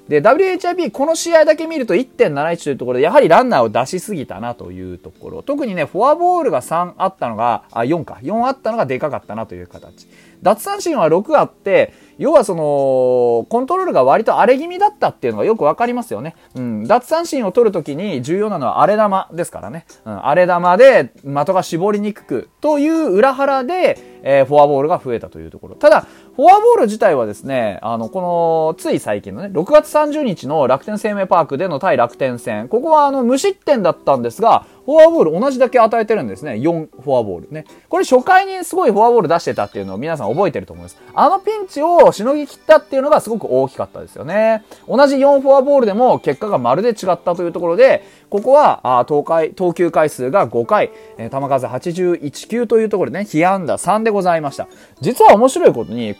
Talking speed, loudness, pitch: 415 characters per minute, -15 LUFS, 210 Hz